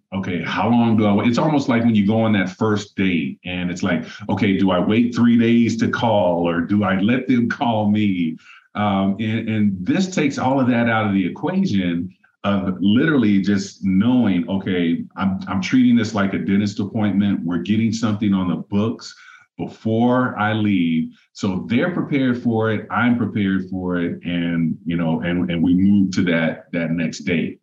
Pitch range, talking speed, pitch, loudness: 95-115 Hz, 195 wpm, 105 Hz, -19 LUFS